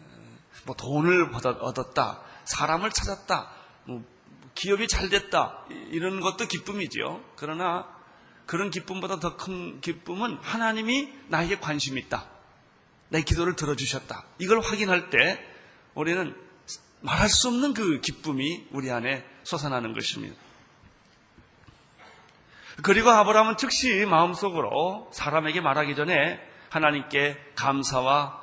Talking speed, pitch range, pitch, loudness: 260 characters per minute, 145-200 Hz, 175 Hz, -26 LUFS